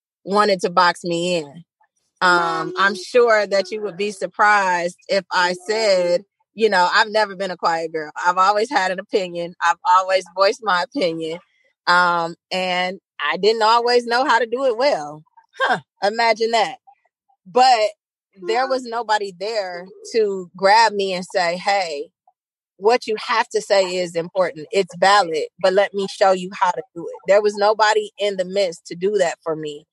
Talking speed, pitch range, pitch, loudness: 175 wpm, 175-220 Hz, 195 Hz, -19 LUFS